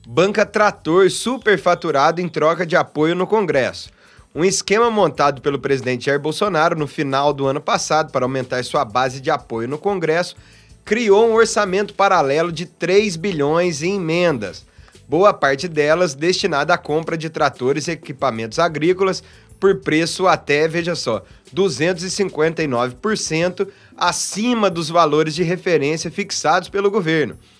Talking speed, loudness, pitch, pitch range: 135 wpm, -18 LUFS, 170 Hz, 150-195 Hz